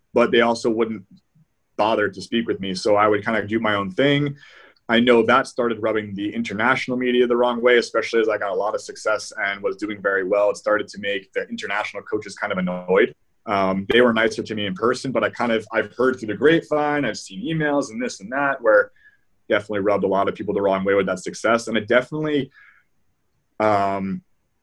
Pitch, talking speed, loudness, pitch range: 115 Hz, 225 wpm, -21 LUFS, 100-135 Hz